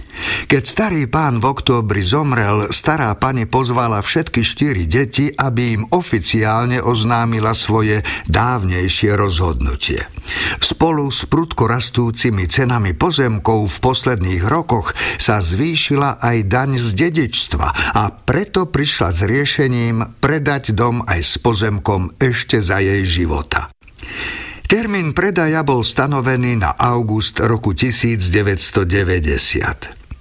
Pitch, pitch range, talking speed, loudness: 120 Hz, 105-135 Hz, 110 wpm, -15 LUFS